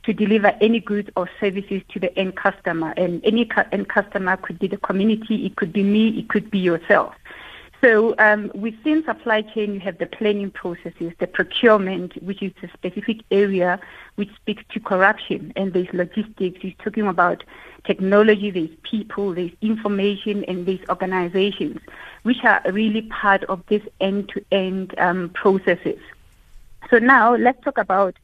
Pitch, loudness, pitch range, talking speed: 200 Hz, -20 LUFS, 185-215 Hz, 165 wpm